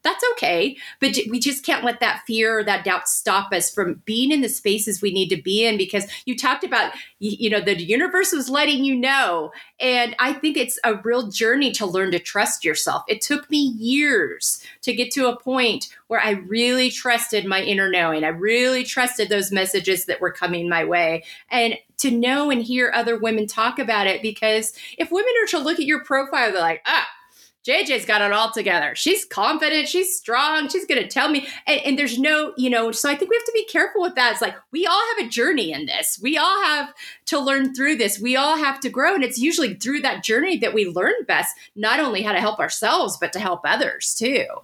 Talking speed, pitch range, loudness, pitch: 225 wpm, 210-290 Hz, -20 LUFS, 245 Hz